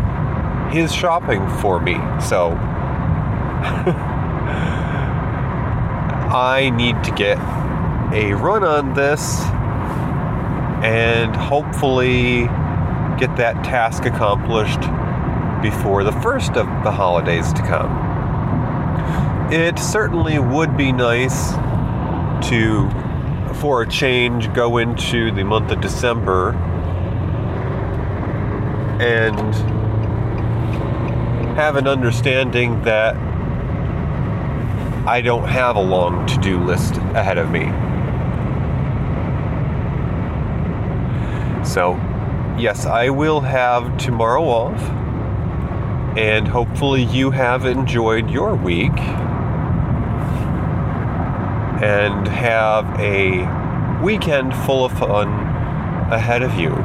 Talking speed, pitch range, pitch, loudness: 85 wpm, 110-130 Hz, 120 Hz, -18 LUFS